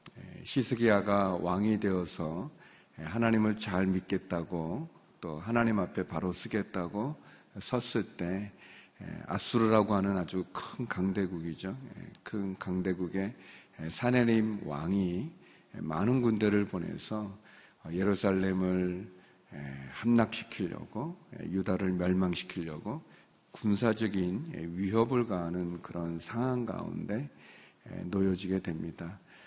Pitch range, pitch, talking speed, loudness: 90-110 Hz, 95 Hz, 225 characters per minute, -32 LUFS